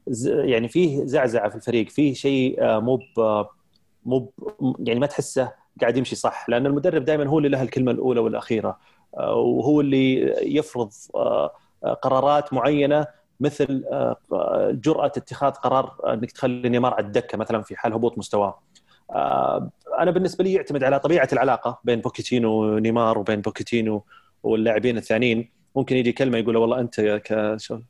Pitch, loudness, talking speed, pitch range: 130 Hz, -22 LUFS, 140 wpm, 115-145 Hz